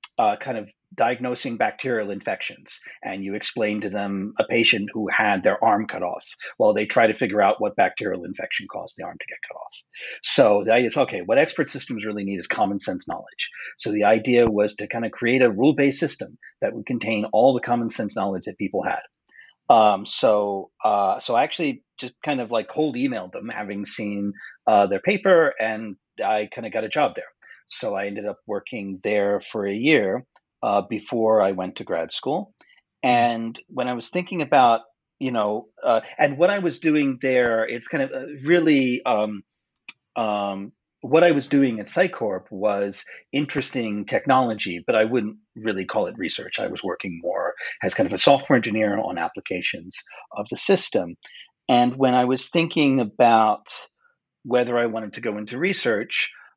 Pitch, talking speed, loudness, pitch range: 115 Hz, 190 wpm, -22 LUFS, 105-130 Hz